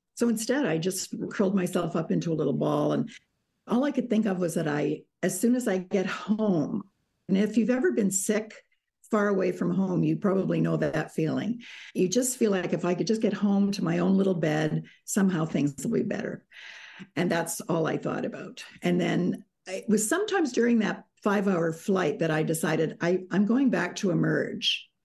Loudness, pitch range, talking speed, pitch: -27 LUFS, 175-215 Hz, 205 wpm, 195 Hz